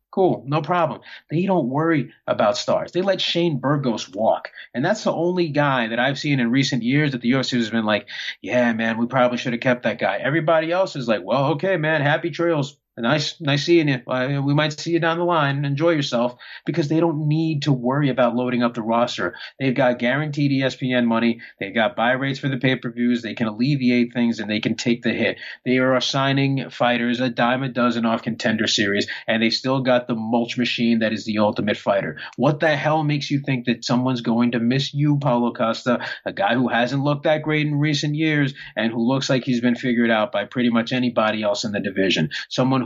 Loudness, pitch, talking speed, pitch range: -21 LUFS, 130 Hz, 225 wpm, 120-150 Hz